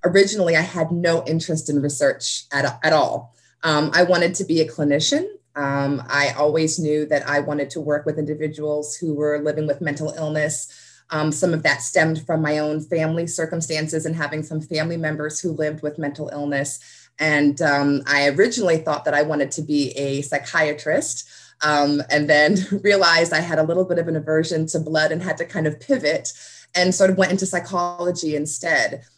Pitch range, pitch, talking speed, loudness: 150-170 Hz, 155 Hz, 190 wpm, -20 LUFS